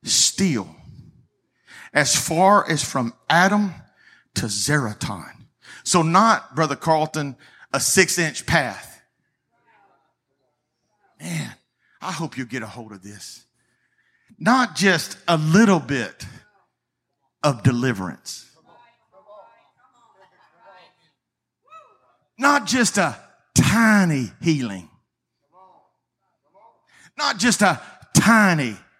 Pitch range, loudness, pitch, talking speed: 125-190 Hz, -20 LUFS, 155 Hz, 85 wpm